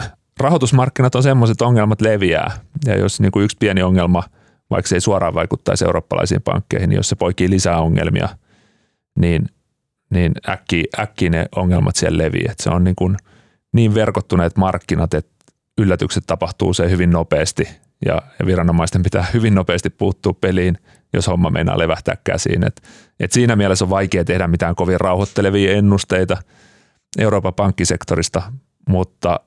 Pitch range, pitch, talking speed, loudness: 90-105 Hz, 95 Hz, 145 wpm, -17 LUFS